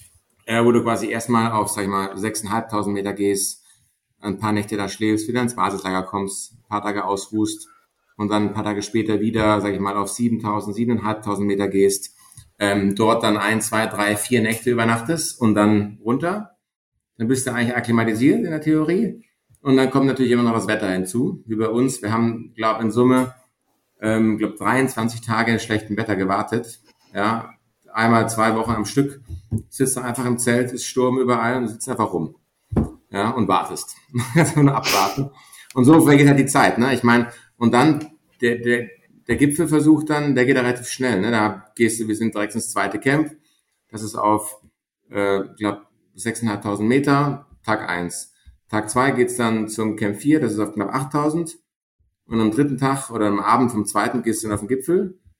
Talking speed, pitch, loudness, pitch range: 190 wpm, 115 Hz, -20 LUFS, 105-125 Hz